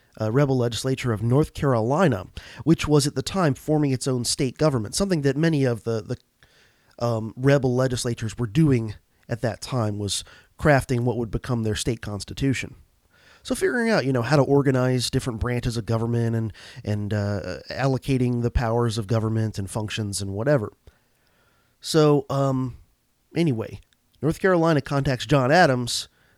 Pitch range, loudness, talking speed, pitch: 110-140 Hz, -23 LUFS, 160 wpm, 125 Hz